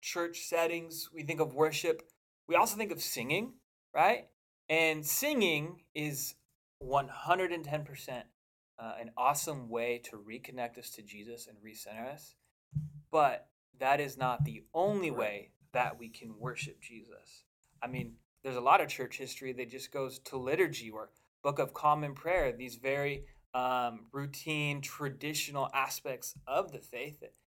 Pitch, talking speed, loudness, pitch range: 140 Hz, 150 wpm, -34 LUFS, 125-155 Hz